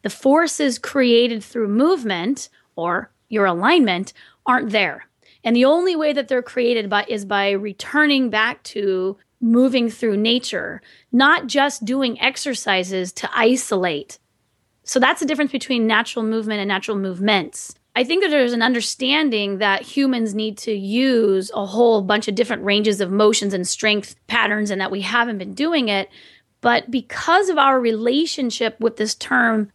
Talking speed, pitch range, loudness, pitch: 160 wpm, 205-260 Hz, -19 LUFS, 230 Hz